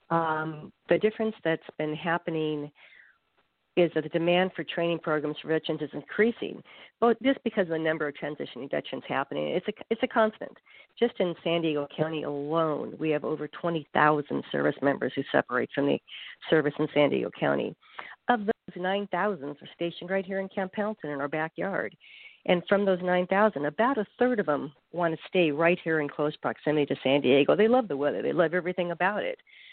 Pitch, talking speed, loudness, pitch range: 170 Hz, 200 wpm, -28 LUFS, 150-195 Hz